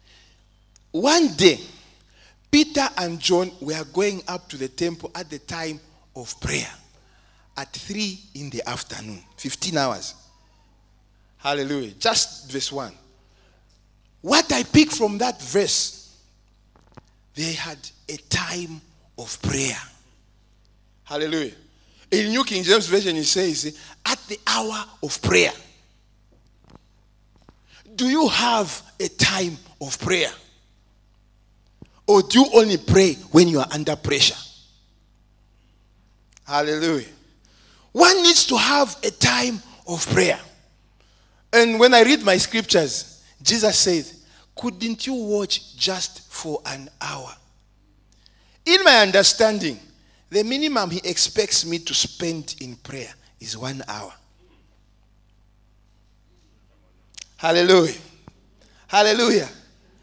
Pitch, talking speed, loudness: 145 Hz, 110 wpm, -19 LUFS